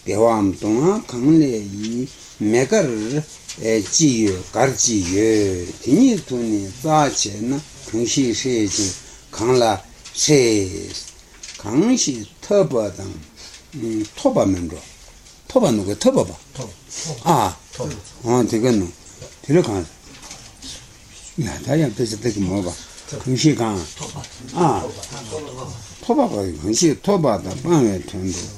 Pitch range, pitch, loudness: 100-140 Hz, 110 Hz, -19 LUFS